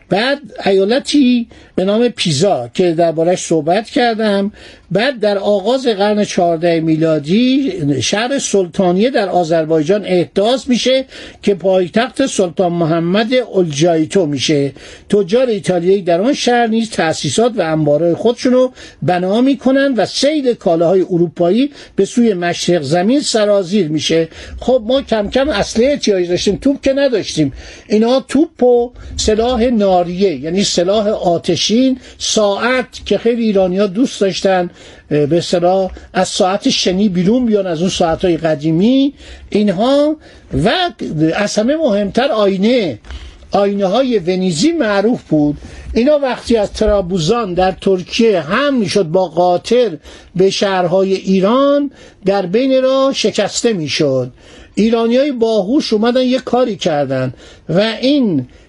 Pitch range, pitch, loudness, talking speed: 180-245 Hz, 205 Hz, -14 LUFS, 125 wpm